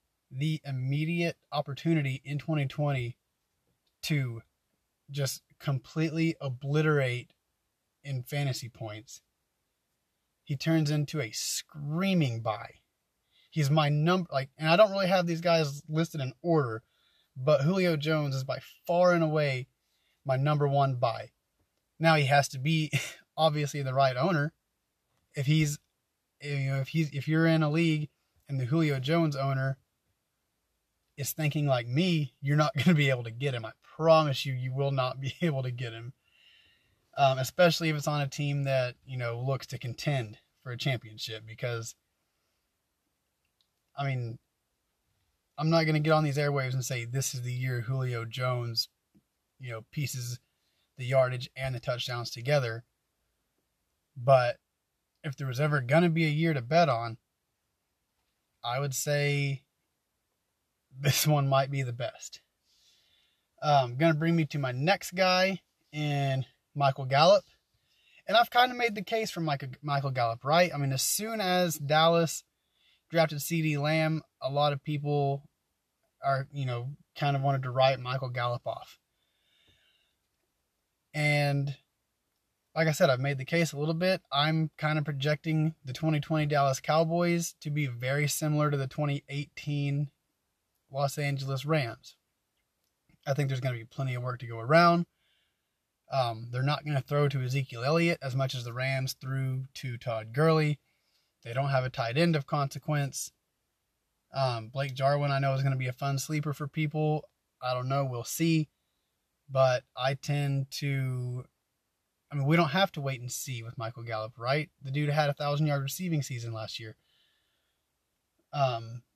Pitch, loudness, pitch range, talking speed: 140 Hz, -29 LUFS, 130-155 Hz, 160 wpm